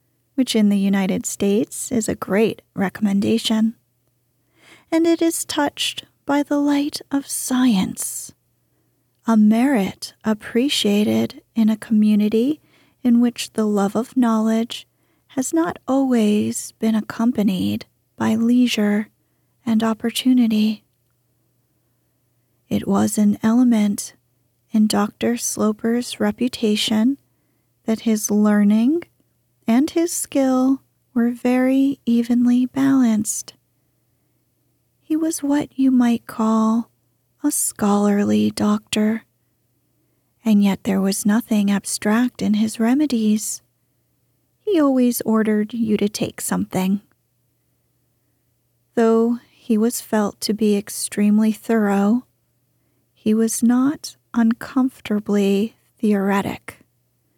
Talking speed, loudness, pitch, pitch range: 100 wpm, -19 LUFS, 220 Hz, 205-245 Hz